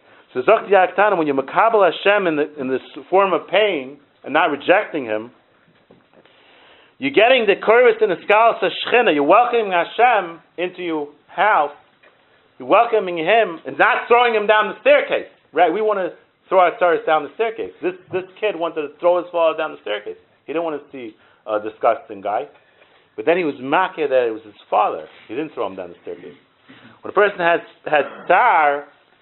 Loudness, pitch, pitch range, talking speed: -18 LUFS, 185 Hz, 160-230 Hz, 185 wpm